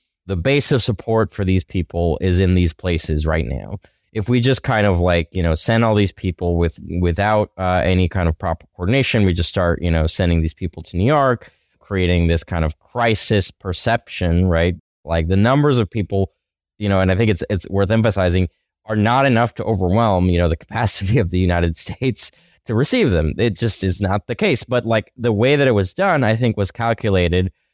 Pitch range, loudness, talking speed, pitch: 85-115 Hz, -18 LUFS, 215 wpm, 95 Hz